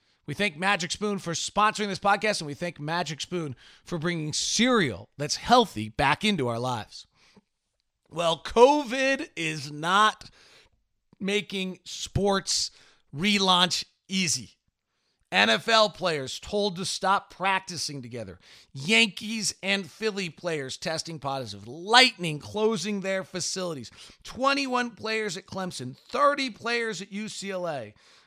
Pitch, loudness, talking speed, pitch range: 190 Hz, -26 LUFS, 115 wpm, 150-210 Hz